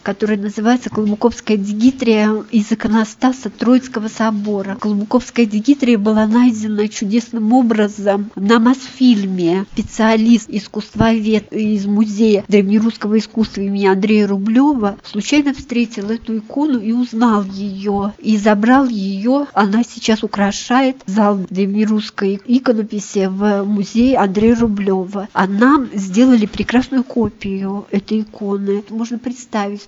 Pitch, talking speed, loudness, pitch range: 215 Hz, 110 wpm, -15 LUFS, 205-235 Hz